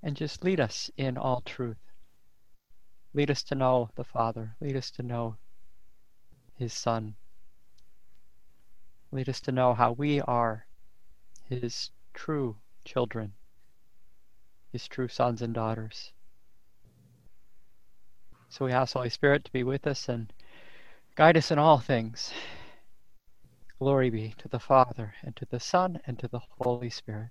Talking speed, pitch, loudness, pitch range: 140 wpm, 125 Hz, -29 LUFS, 110-135 Hz